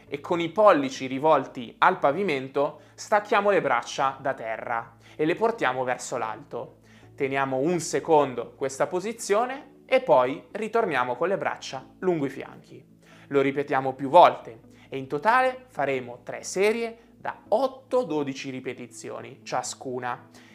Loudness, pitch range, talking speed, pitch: -25 LUFS, 125-180 Hz, 130 wpm, 140 Hz